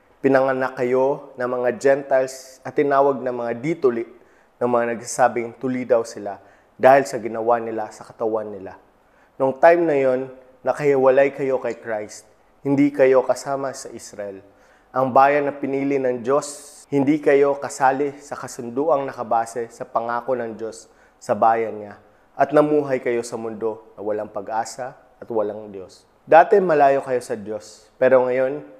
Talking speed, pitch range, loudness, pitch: 150 wpm, 115-140 Hz, -20 LUFS, 130 Hz